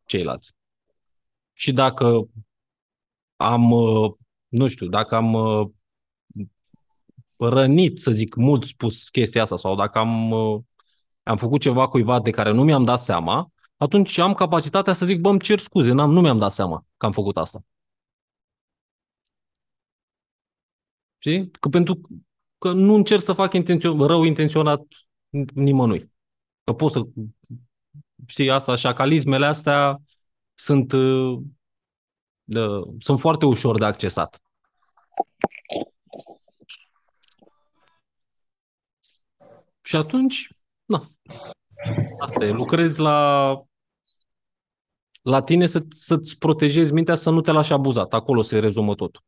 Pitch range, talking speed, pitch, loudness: 110-155 Hz, 115 wpm, 135 Hz, -20 LUFS